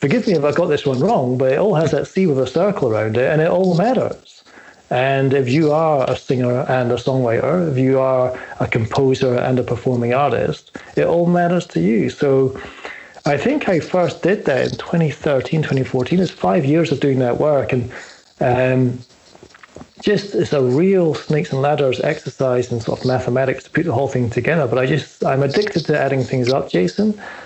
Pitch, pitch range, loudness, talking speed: 140 Hz, 130-170 Hz, -17 LUFS, 205 wpm